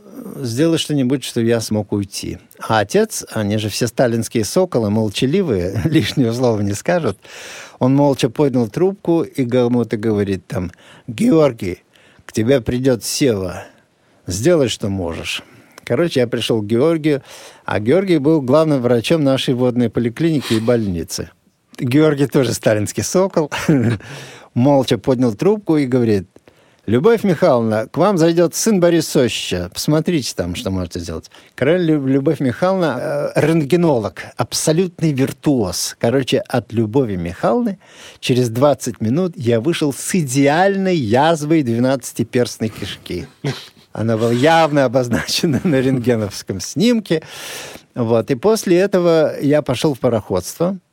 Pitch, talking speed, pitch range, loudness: 135 Hz, 125 wpm, 115-160 Hz, -17 LUFS